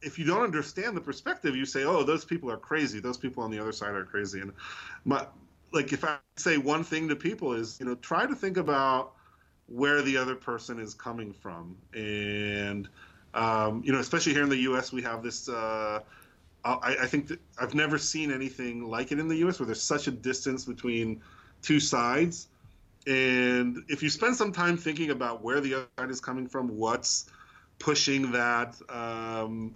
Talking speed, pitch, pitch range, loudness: 200 wpm, 130 Hz, 115-145 Hz, -29 LUFS